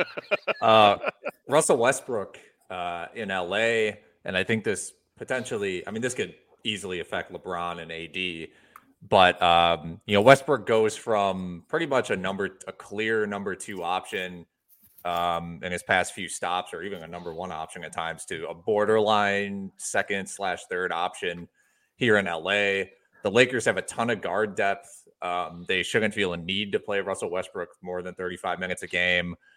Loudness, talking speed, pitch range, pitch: -26 LUFS, 160 wpm, 85-105 Hz, 90 Hz